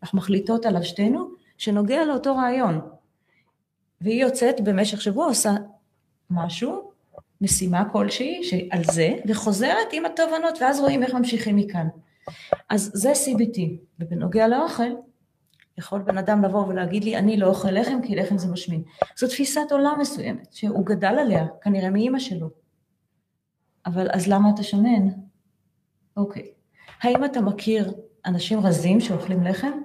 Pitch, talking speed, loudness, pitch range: 205 Hz, 135 wpm, -23 LUFS, 185-240 Hz